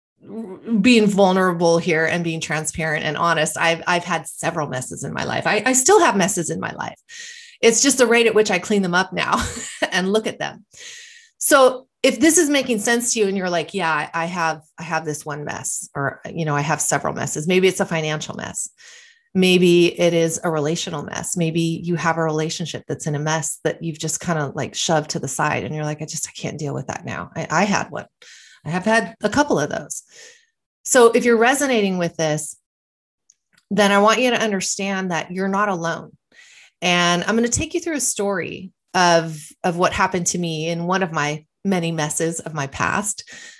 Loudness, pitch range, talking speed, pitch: -19 LUFS, 160-220 Hz, 215 wpm, 180 Hz